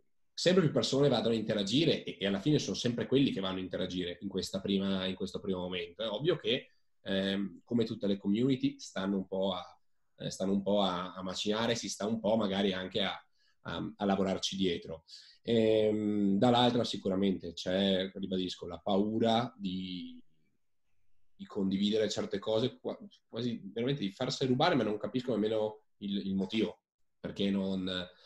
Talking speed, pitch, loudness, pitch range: 170 wpm, 100 Hz, -32 LUFS, 95-110 Hz